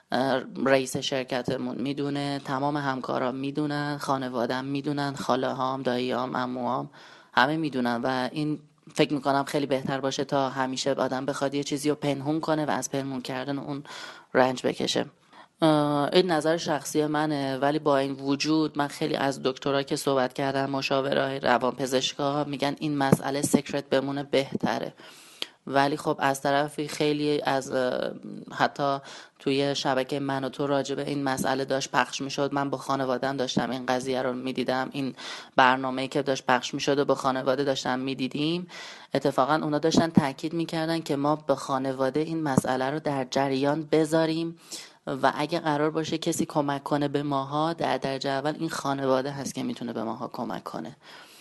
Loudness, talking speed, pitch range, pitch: -27 LUFS, 160 wpm, 135-150 Hz, 140 Hz